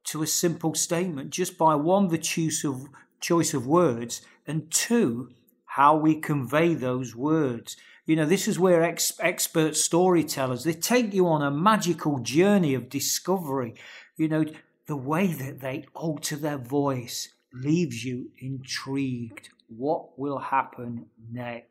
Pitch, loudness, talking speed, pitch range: 155 Hz, -25 LUFS, 145 wpm, 135-165 Hz